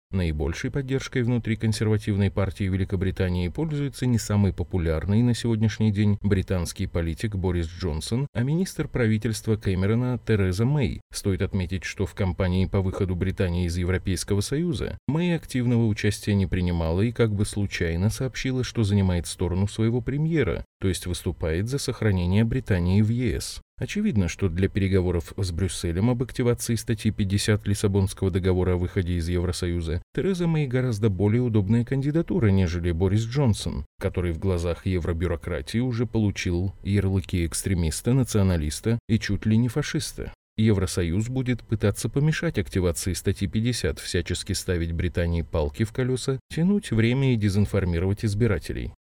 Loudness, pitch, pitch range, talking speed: -25 LUFS, 100 Hz, 90-115 Hz, 140 wpm